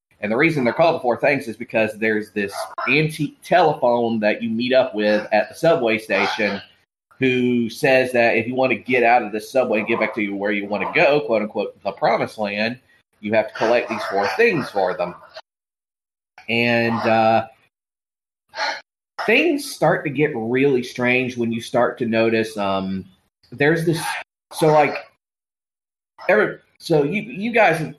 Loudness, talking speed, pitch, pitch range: -19 LUFS, 175 wpm, 120 Hz, 110-140 Hz